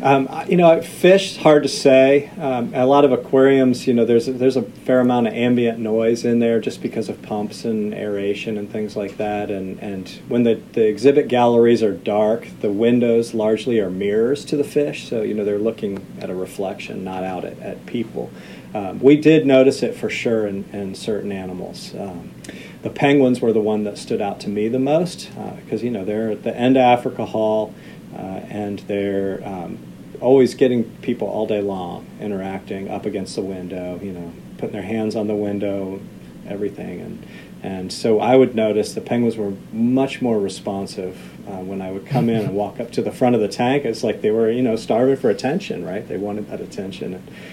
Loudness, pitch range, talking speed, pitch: -19 LUFS, 105-130 Hz, 210 wpm, 115 Hz